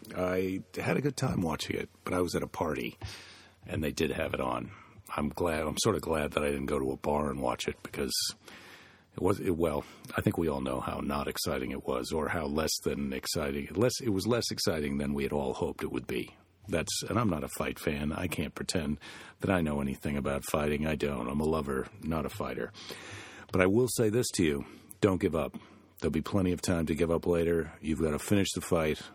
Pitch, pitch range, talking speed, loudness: 80 Hz, 75-95 Hz, 240 wpm, -32 LUFS